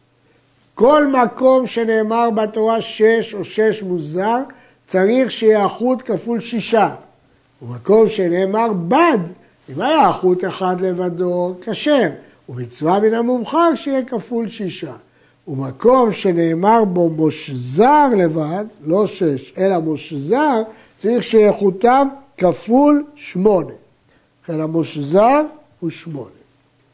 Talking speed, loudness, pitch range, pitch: 100 wpm, -16 LUFS, 165-230 Hz, 200 Hz